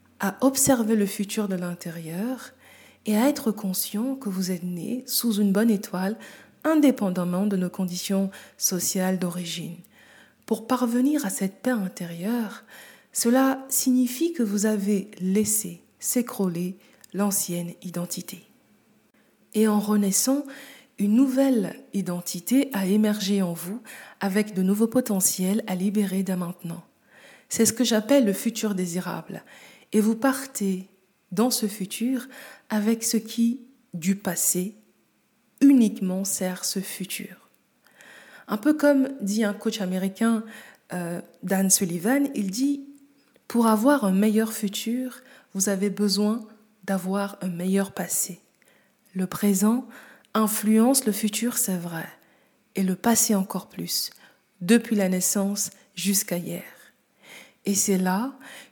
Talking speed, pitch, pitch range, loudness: 125 wpm, 210 Hz, 190-245 Hz, -24 LUFS